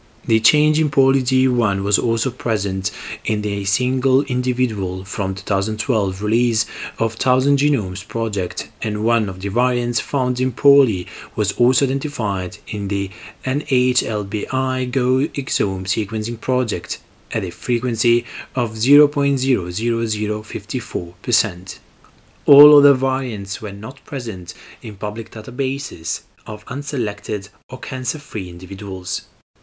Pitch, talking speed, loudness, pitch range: 115 Hz, 115 wpm, -19 LUFS, 105-130 Hz